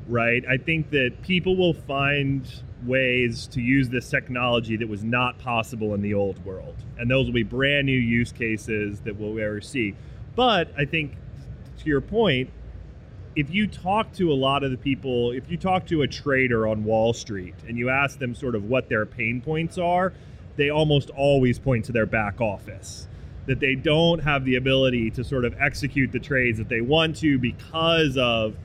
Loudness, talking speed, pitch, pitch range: -23 LUFS, 195 wpm, 125 Hz, 115-140 Hz